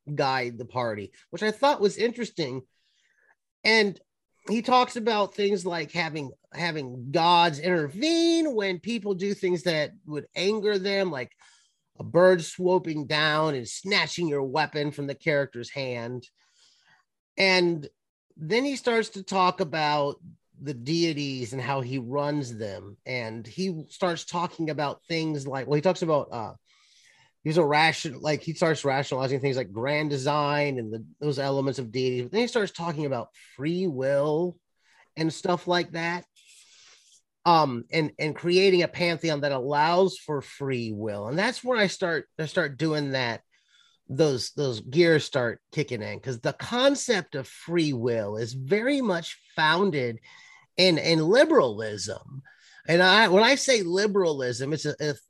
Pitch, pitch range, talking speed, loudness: 155 Hz, 135-185 Hz, 155 wpm, -25 LUFS